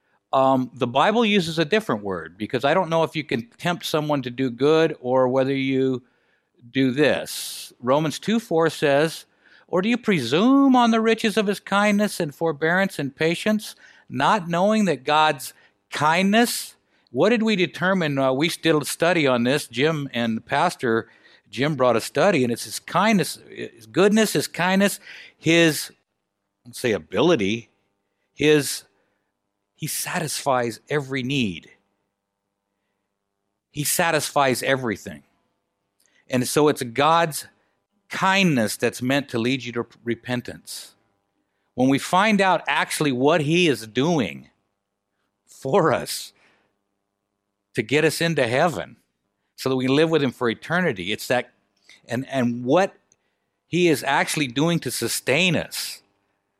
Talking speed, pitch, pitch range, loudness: 145 wpm, 135 Hz, 110-165 Hz, -21 LUFS